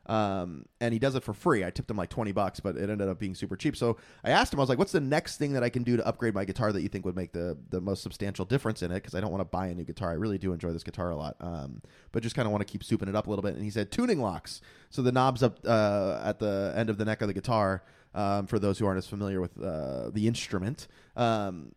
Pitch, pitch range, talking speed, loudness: 105 Hz, 95-115 Hz, 310 wpm, -30 LUFS